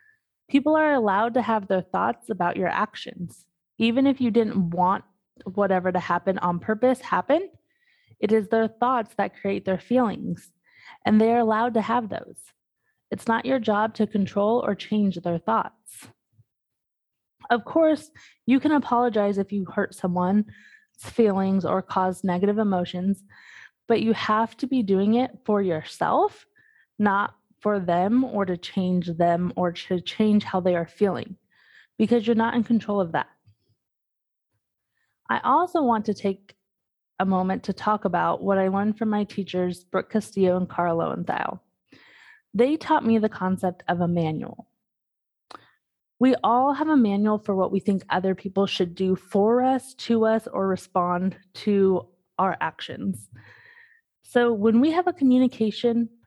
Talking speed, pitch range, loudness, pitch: 155 wpm, 185-240 Hz, -24 LUFS, 210 Hz